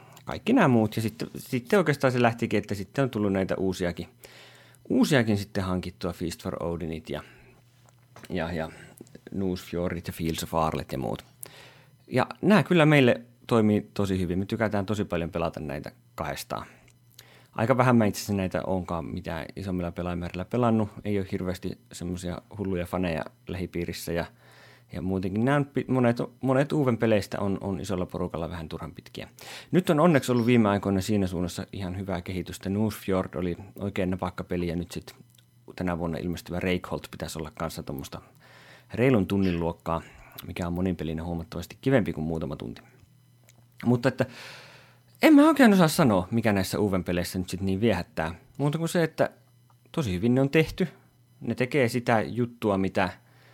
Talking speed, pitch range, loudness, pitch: 160 wpm, 90-125 Hz, -27 LUFS, 100 Hz